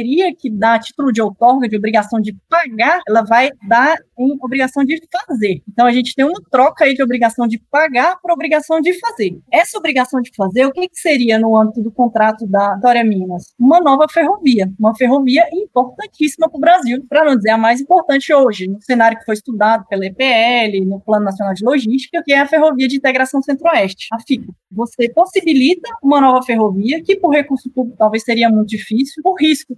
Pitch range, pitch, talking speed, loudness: 225-305 Hz, 255 Hz, 200 wpm, -14 LUFS